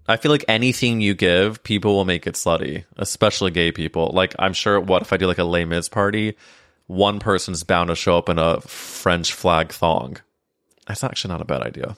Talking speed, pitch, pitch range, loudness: 210 wpm, 95 Hz, 85-105 Hz, -20 LUFS